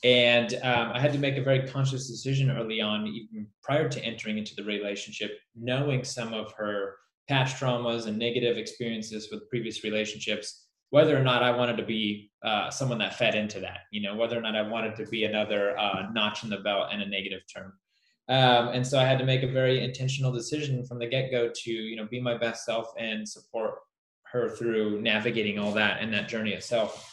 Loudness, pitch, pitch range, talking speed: -28 LUFS, 115 Hz, 110-130 Hz, 210 wpm